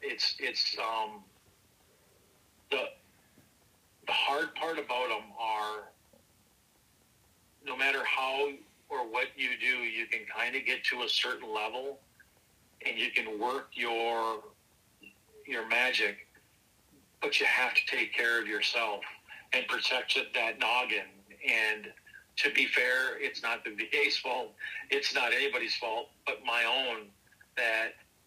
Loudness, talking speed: -30 LUFS, 130 wpm